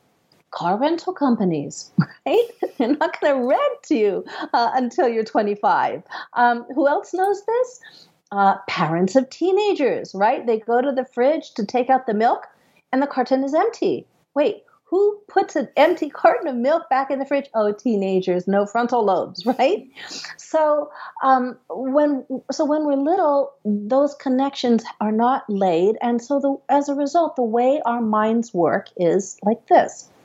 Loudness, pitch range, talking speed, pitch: -20 LUFS, 230-305 Hz, 165 wpm, 265 Hz